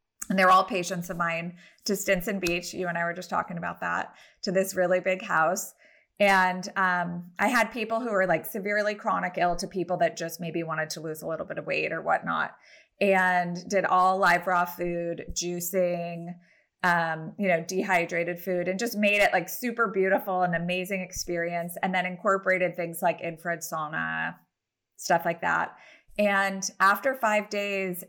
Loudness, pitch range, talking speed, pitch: -27 LUFS, 175-195 Hz, 180 wpm, 185 Hz